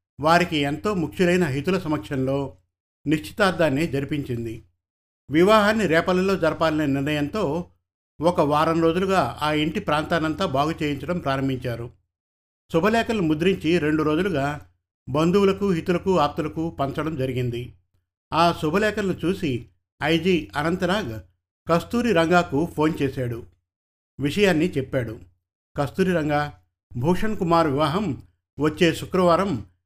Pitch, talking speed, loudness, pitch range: 150 Hz, 95 wpm, -22 LUFS, 120-175 Hz